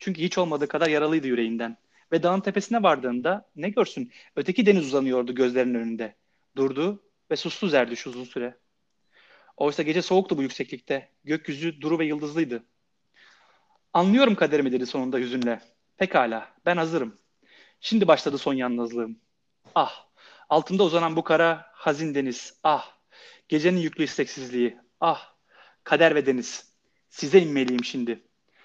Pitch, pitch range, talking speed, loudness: 150 Hz, 125-170 Hz, 130 wpm, -25 LUFS